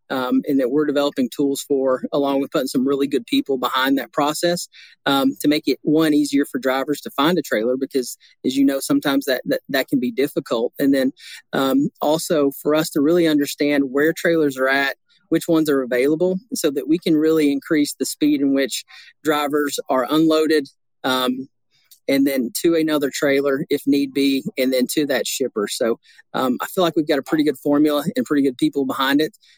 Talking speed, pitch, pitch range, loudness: 205 wpm, 145 Hz, 135-160 Hz, -20 LUFS